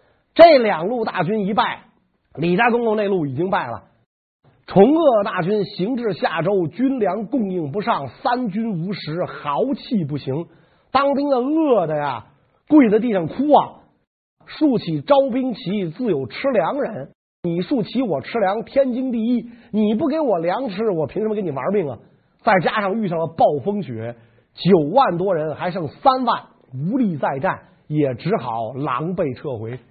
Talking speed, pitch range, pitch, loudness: 230 characters per minute, 165-245 Hz, 200 Hz, -20 LUFS